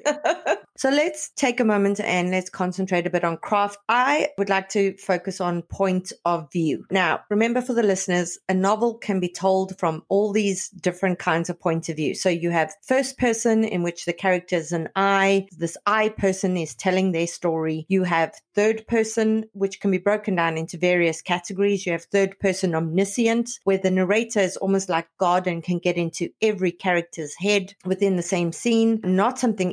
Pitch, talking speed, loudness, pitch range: 190 Hz, 195 wpm, -23 LUFS, 175-205 Hz